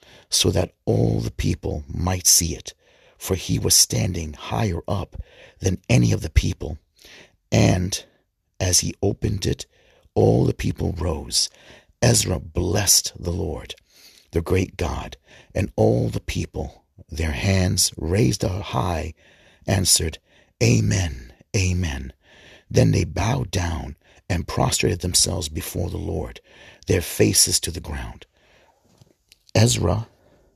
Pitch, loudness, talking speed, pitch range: 90 Hz, -21 LUFS, 125 wpm, 80-100 Hz